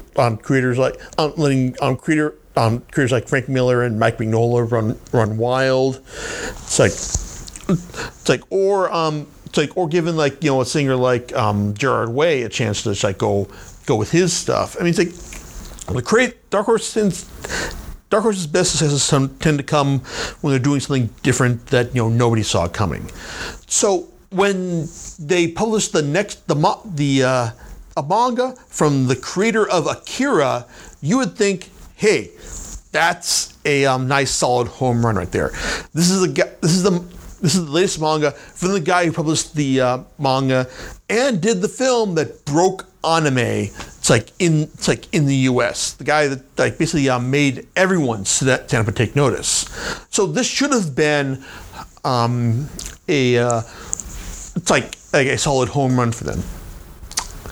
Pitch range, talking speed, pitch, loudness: 125-175 Hz, 170 wpm, 145 Hz, -19 LUFS